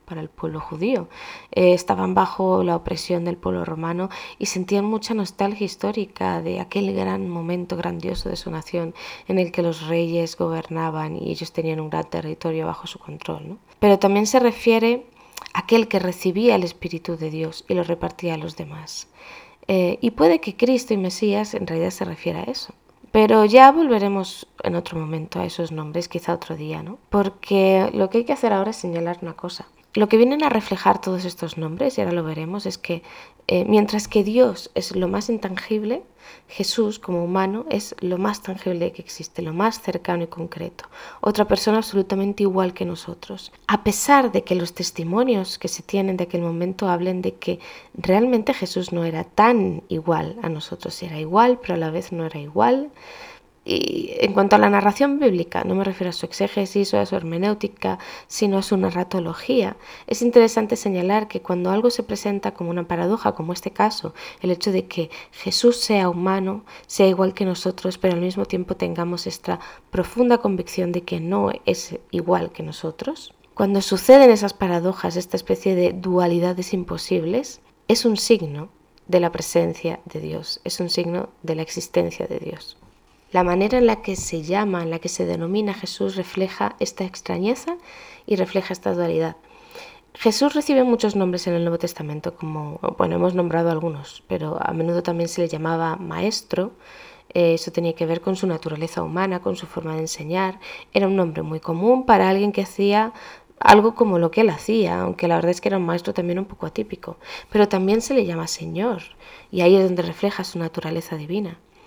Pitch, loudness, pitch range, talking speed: 185 Hz, -21 LUFS, 170-210 Hz, 190 wpm